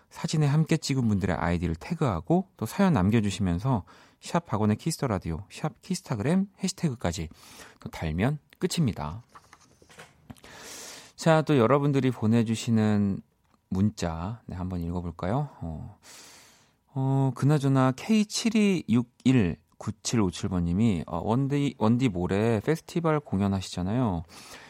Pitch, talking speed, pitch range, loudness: 125 Hz, 250 characters per minute, 95-150 Hz, -27 LUFS